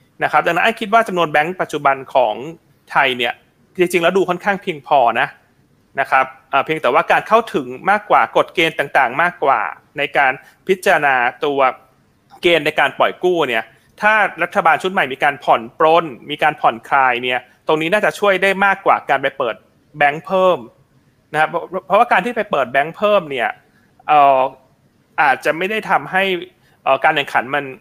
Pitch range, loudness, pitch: 140-195 Hz, -16 LUFS, 165 Hz